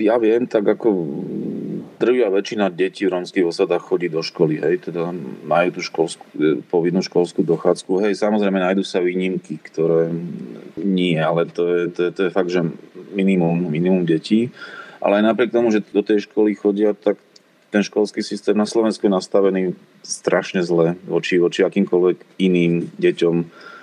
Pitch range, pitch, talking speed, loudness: 85-105 Hz, 95 Hz, 160 wpm, -19 LUFS